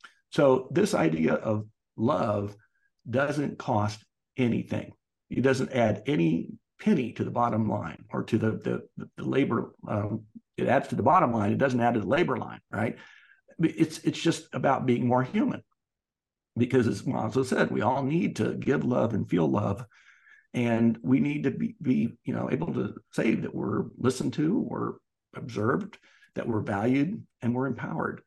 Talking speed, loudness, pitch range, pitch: 170 wpm, -28 LUFS, 105-130 Hz, 120 Hz